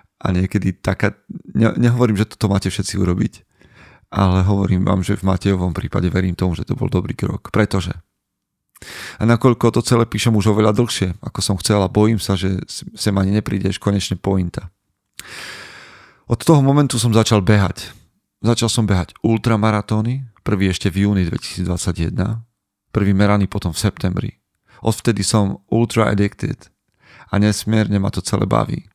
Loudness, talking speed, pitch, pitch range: -18 LUFS, 155 wpm, 100 Hz, 95-110 Hz